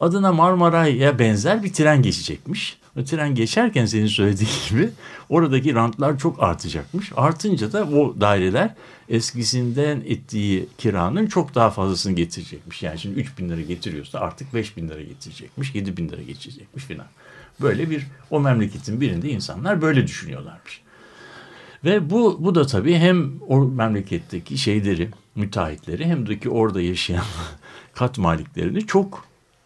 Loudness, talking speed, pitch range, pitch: -21 LUFS, 140 wpm, 105-165 Hz, 130 Hz